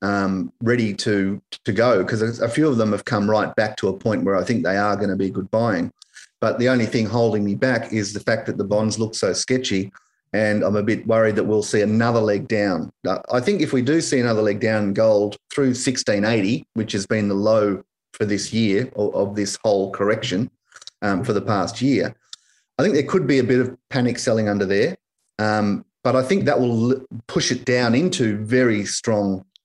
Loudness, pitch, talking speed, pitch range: -21 LUFS, 110 Hz, 220 wpm, 105-125 Hz